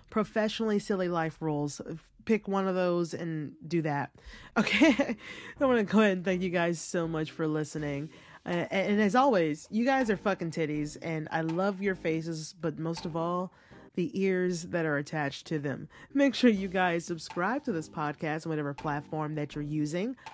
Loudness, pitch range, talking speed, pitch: -30 LUFS, 155-200 Hz, 190 wpm, 170 Hz